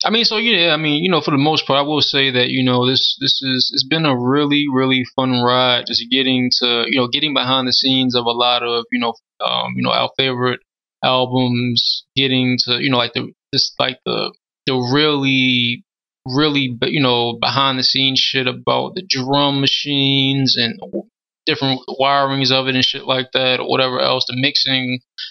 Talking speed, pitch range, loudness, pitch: 200 wpm, 125-135 Hz, -16 LUFS, 130 Hz